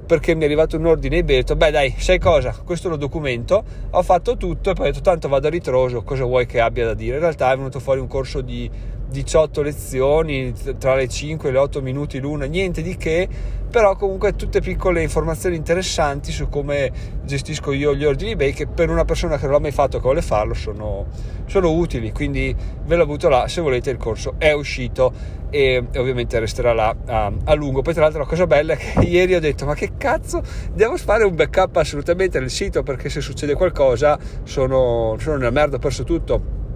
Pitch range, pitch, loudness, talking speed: 130-165 Hz, 145 Hz, -19 LUFS, 215 wpm